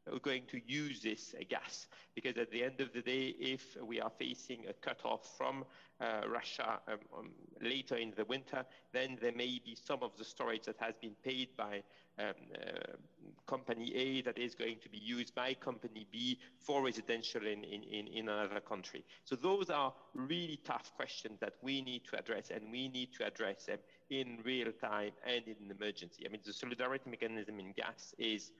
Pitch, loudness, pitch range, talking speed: 120 Hz, -42 LUFS, 110-130 Hz, 195 wpm